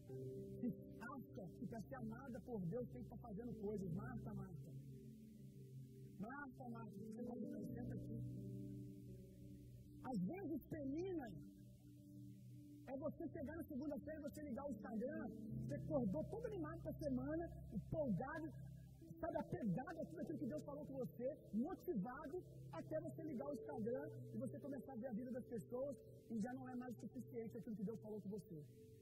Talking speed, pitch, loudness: 165 wpm, 170 Hz, -50 LUFS